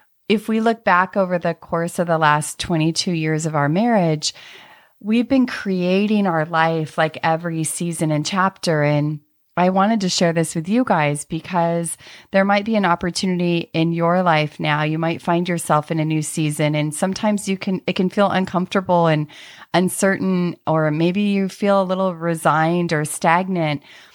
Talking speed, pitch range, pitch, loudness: 175 wpm, 160-190 Hz, 170 Hz, -19 LUFS